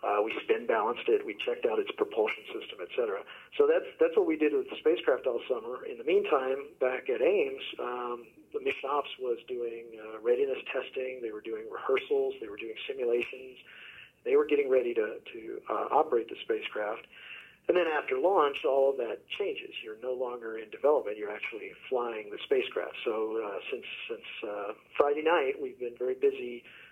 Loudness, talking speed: -31 LUFS, 190 wpm